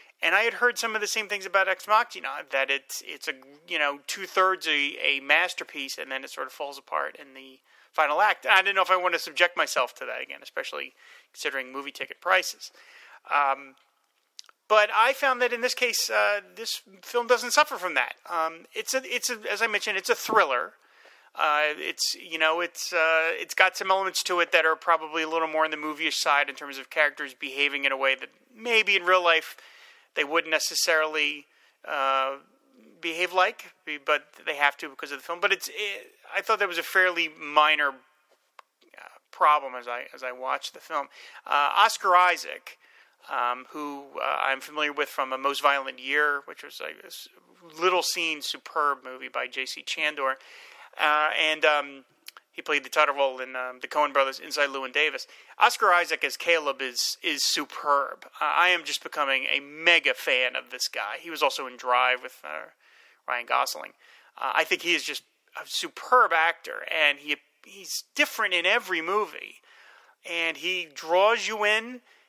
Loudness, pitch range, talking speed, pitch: -25 LUFS, 145-210 Hz, 195 wpm, 160 Hz